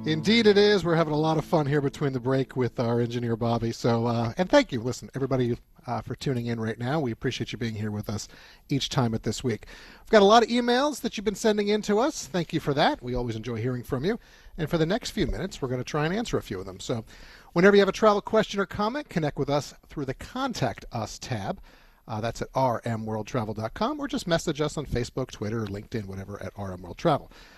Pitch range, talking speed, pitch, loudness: 115-190 Hz, 250 wpm, 135 Hz, -26 LUFS